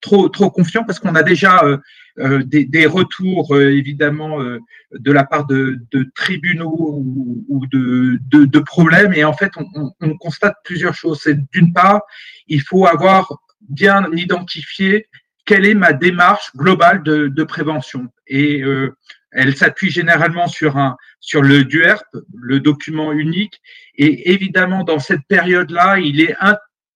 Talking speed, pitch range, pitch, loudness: 165 wpm, 145-185 Hz, 160 Hz, -14 LUFS